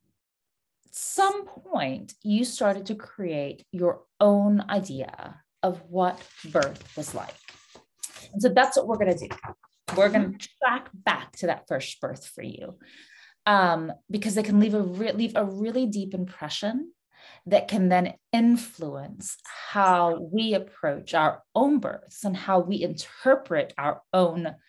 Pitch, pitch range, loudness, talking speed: 205 Hz, 180-230 Hz, -26 LUFS, 145 wpm